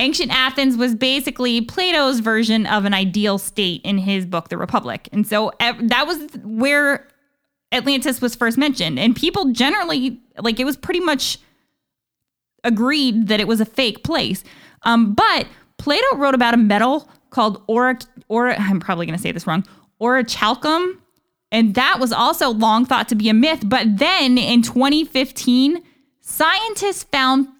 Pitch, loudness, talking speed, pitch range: 250 Hz, -17 LUFS, 165 wpm, 220-280 Hz